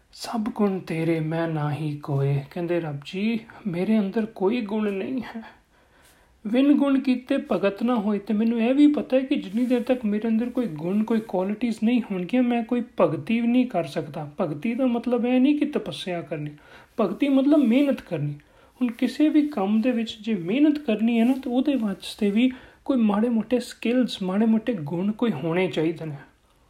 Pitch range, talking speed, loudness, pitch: 185-250 Hz, 180 wpm, -24 LUFS, 225 Hz